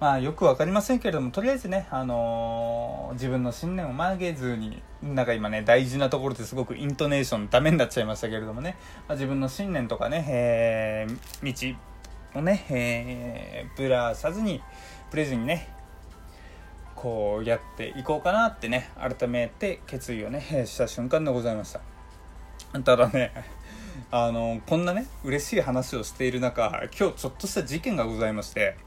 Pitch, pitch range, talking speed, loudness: 125 Hz, 115-145 Hz, 345 characters per minute, -27 LUFS